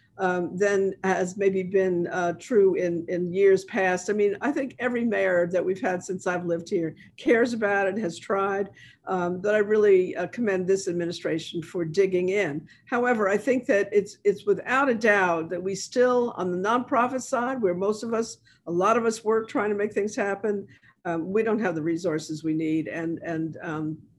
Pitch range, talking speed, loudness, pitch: 175-215 Hz, 205 wpm, -25 LUFS, 195 Hz